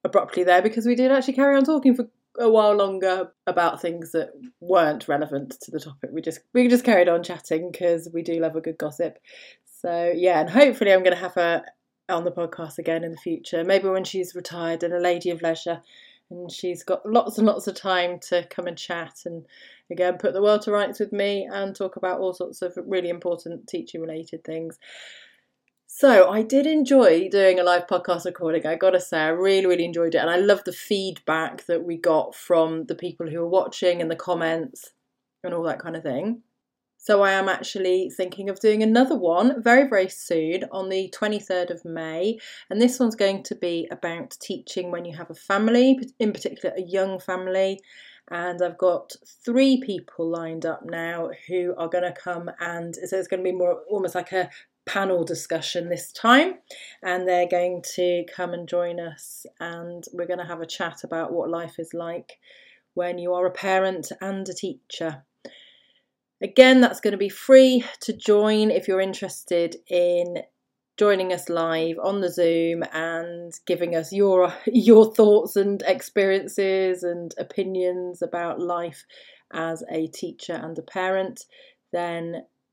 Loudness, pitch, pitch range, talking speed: -22 LUFS, 180 Hz, 170-200 Hz, 185 wpm